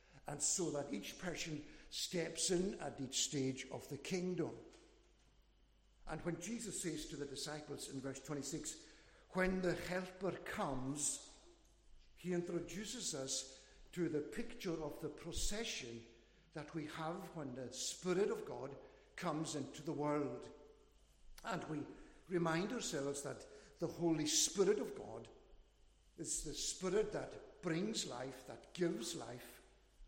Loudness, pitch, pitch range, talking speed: -42 LUFS, 160 Hz, 140-180 Hz, 135 wpm